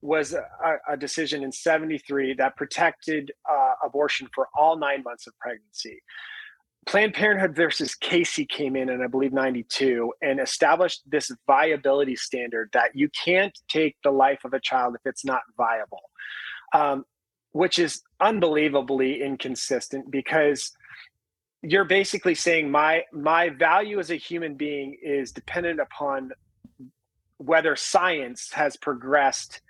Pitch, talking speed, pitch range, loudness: 150 Hz, 140 wpm, 135-175 Hz, -24 LUFS